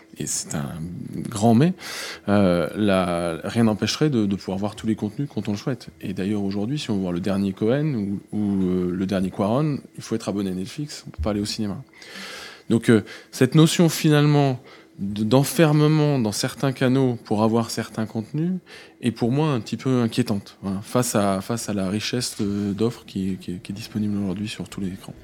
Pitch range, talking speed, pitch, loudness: 100-130 Hz, 205 wpm, 110 Hz, -23 LUFS